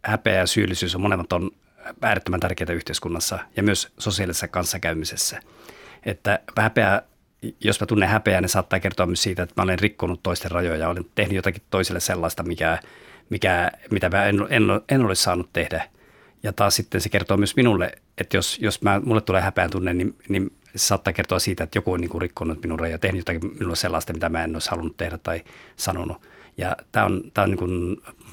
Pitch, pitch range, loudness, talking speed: 95 Hz, 85-100 Hz, -23 LUFS, 195 wpm